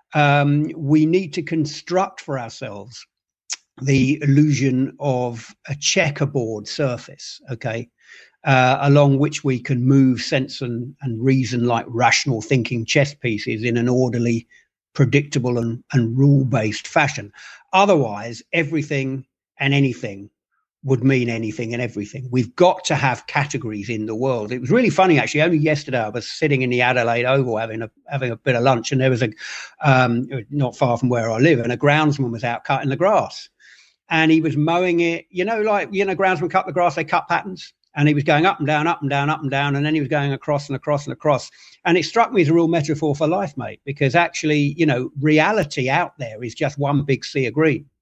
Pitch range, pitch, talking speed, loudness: 125-155 Hz, 140 Hz, 200 wpm, -19 LUFS